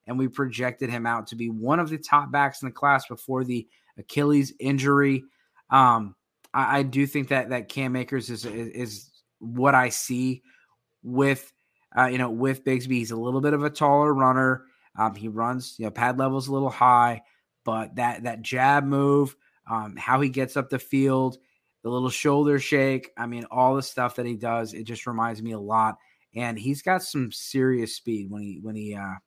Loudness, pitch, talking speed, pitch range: -24 LUFS, 130 Hz, 205 wpm, 115-135 Hz